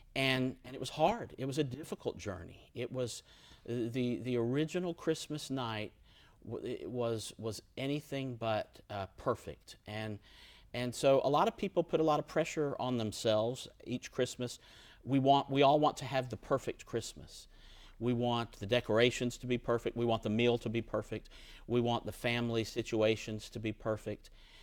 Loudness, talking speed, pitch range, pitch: -35 LUFS, 175 wpm, 110-135 Hz, 120 Hz